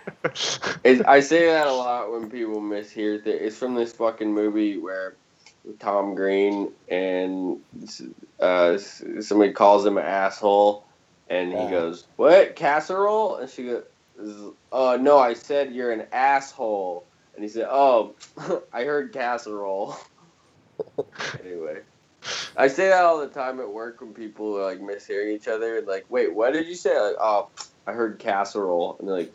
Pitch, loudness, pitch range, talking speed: 110 Hz, -23 LUFS, 100-140 Hz, 160 wpm